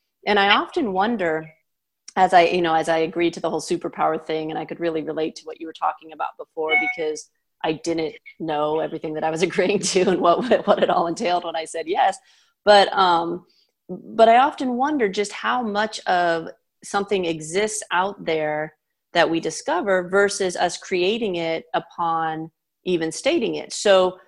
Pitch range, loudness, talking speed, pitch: 160-205 Hz, -21 LUFS, 185 wpm, 175 Hz